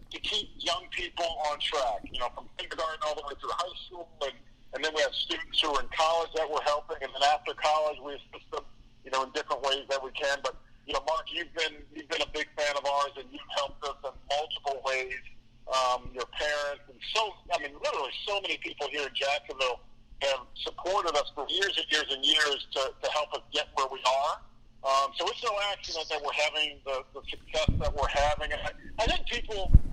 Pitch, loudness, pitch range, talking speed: 145 Hz, -30 LUFS, 135-160 Hz, 225 wpm